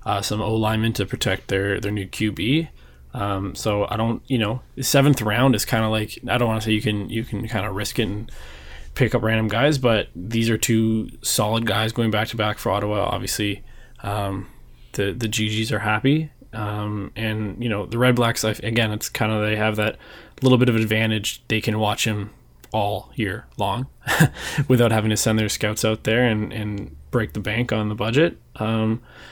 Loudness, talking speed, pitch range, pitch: -22 LUFS, 210 wpm, 105-115 Hz, 110 Hz